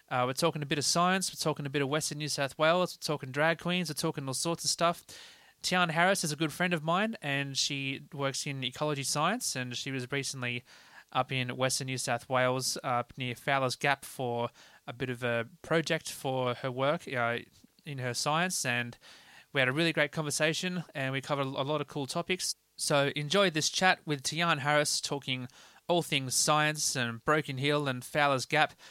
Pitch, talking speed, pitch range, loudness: 145 Hz, 210 wpm, 130-160 Hz, -30 LUFS